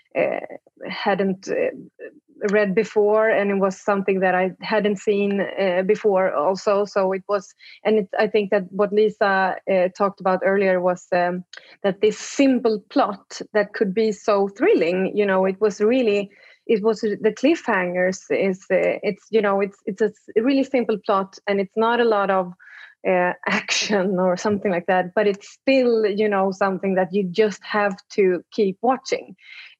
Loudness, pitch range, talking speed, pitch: -21 LUFS, 190-220 Hz, 175 wpm, 205 Hz